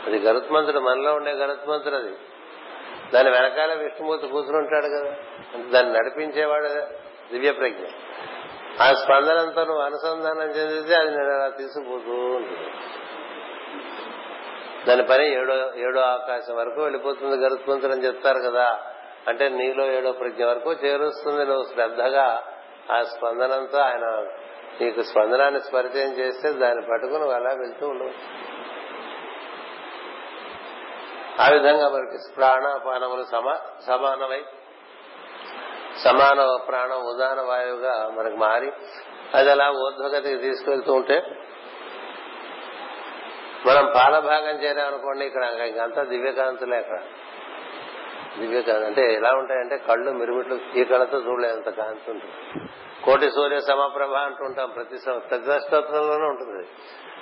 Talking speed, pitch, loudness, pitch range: 105 wpm, 135 Hz, -22 LUFS, 125-145 Hz